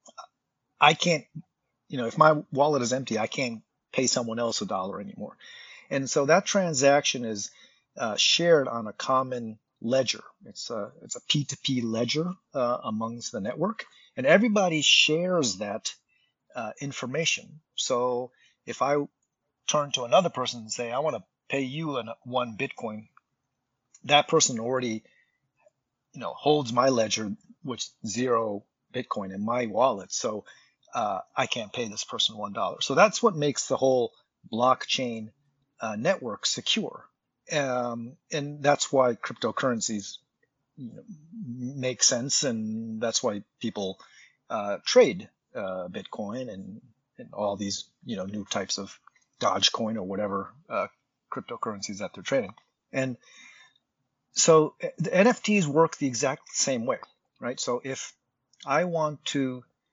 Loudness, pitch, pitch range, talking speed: -26 LUFS, 130 Hz, 115-150 Hz, 140 wpm